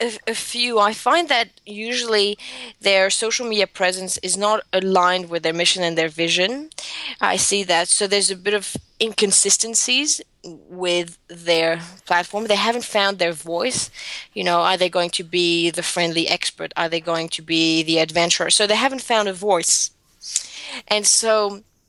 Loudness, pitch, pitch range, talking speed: -19 LUFS, 190 Hz, 170-215 Hz, 165 wpm